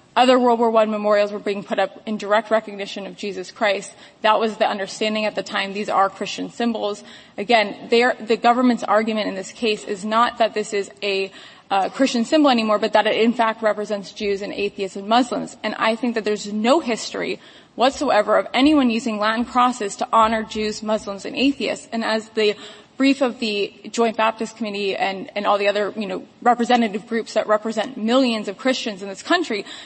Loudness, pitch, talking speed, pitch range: -20 LUFS, 220 Hz, 200 wpm, 205-235 Hz